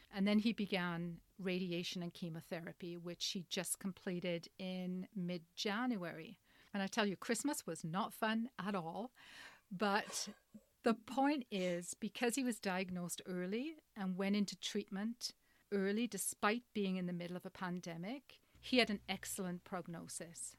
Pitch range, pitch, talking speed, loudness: 180-220 Hz, 195 Hz, 150 wpm, -41 LUFS